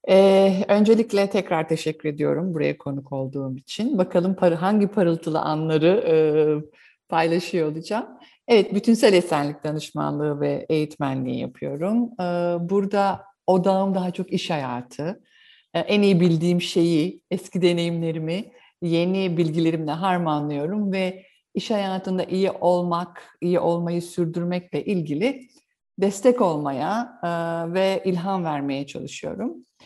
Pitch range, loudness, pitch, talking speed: 155-195 Hz, -23 LUFS, 175 Hz, 115 wpm